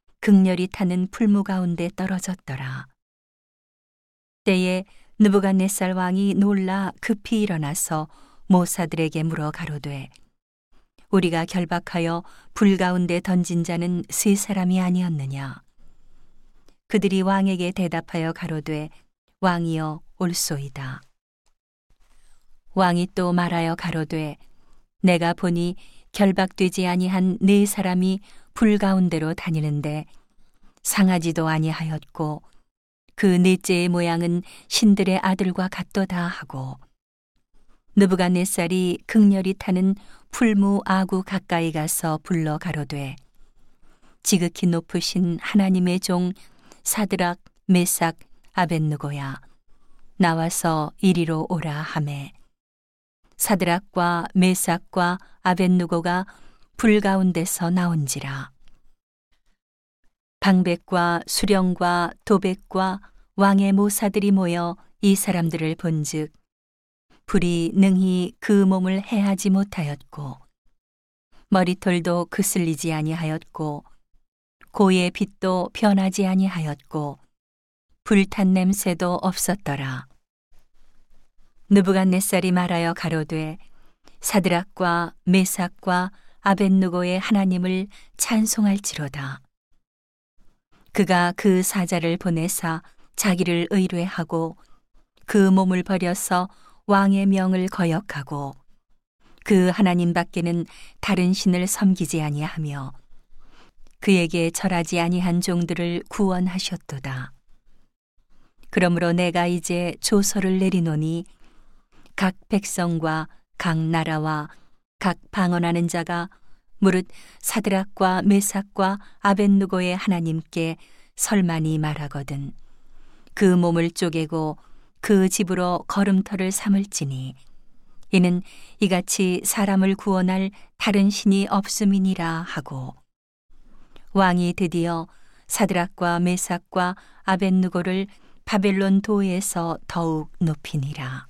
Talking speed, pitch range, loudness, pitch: 220 characters per minute, 165-195 Hz, -22 LUFS, 180 Hz